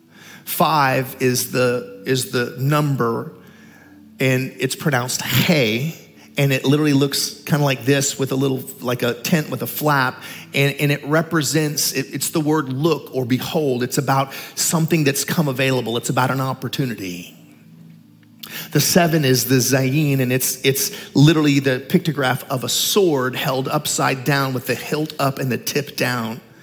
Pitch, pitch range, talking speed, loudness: 135 Hz, 125-150 Hz, 165 wpm, -19 LUFS